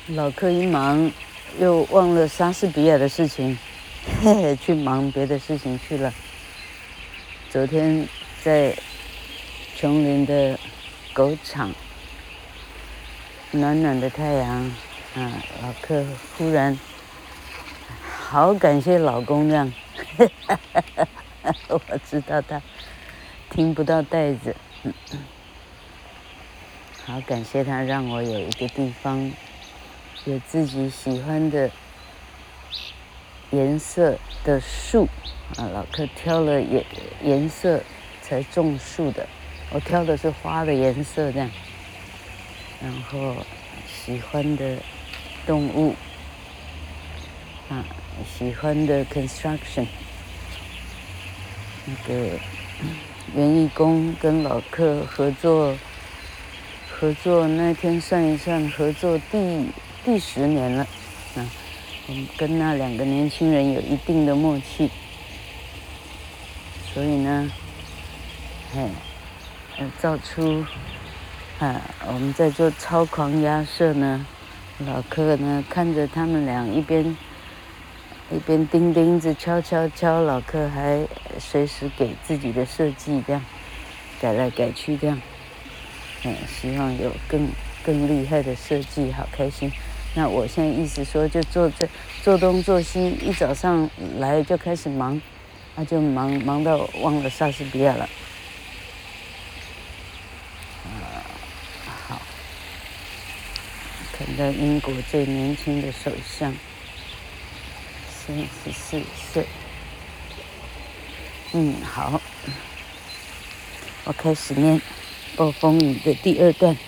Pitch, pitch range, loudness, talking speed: 135 Hz, 90-150 Hz, -23 LUFS, 155 characters per minute